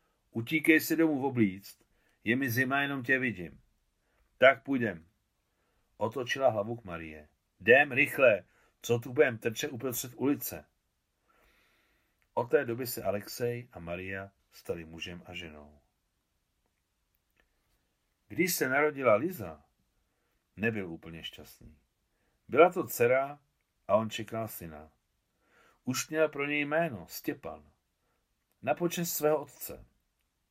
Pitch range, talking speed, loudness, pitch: 90-140 Hz, 120 wpm, -30 LUFS, 120 Hz